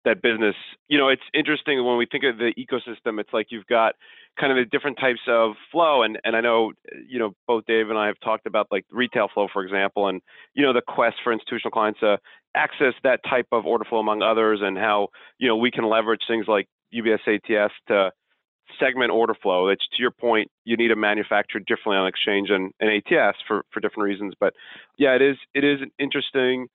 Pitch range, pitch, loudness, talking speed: 105-125 Hz, 115 Hz, -22 LUFS, 220 wpm